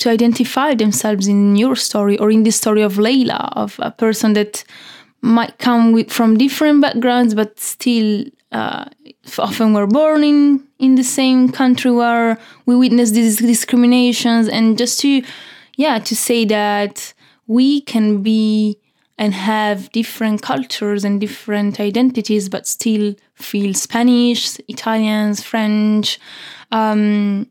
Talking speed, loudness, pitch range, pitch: 135 wpm, -15 LUFS, 210-245 Hz, 225 Hz